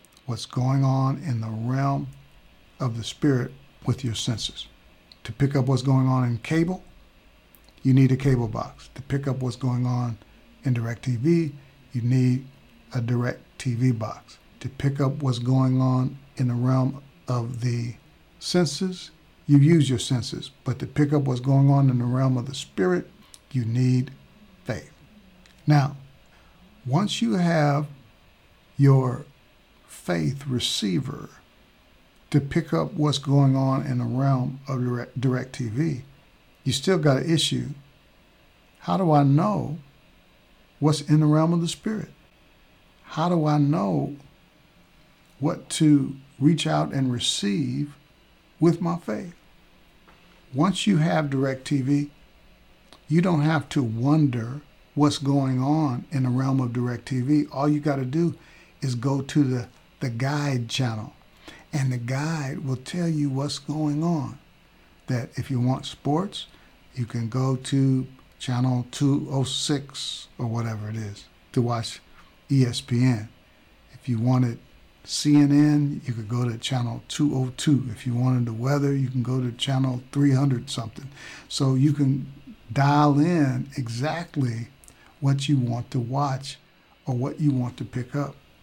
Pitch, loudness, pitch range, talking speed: 135 Hz, -24 LUFS, 125-150 Hz, 150 wpm